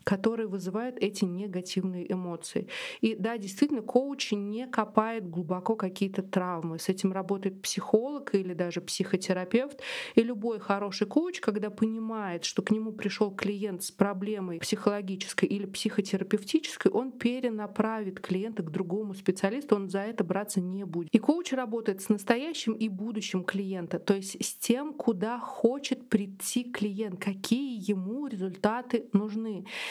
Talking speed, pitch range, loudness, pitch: 140 wpm, 195-230 Hz, -31 LUFS, 210 Hz